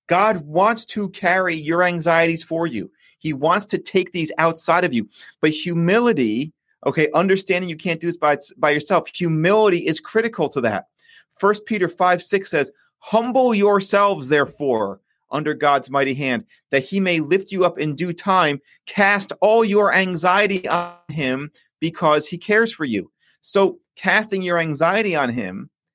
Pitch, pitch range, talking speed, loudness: 180 Hz, 155-200 Hz, 160 wpm, -19 LUFS